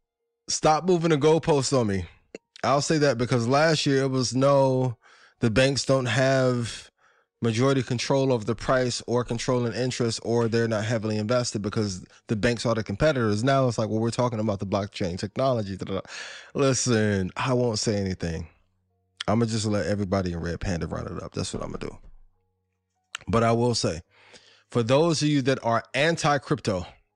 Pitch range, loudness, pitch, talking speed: 100-130 Hz, -25 LUFS, 115 Hz, 180 wpm